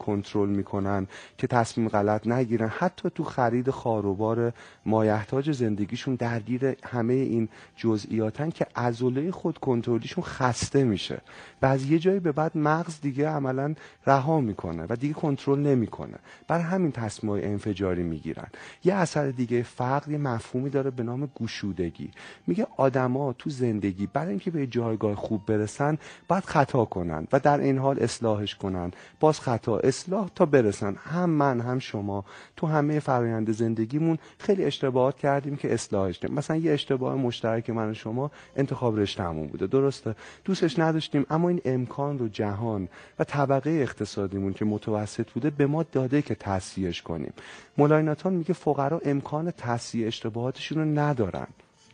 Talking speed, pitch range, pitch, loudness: 150 wpm, 110-145 Hz, 125 Hz, -27 LUFS